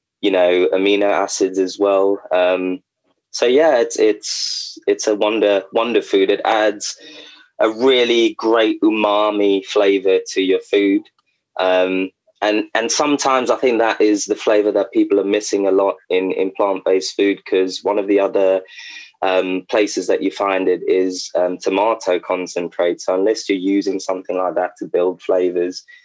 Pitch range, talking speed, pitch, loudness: 95-110 Hz, 165 wpm, 100 Hz, -17 LUFS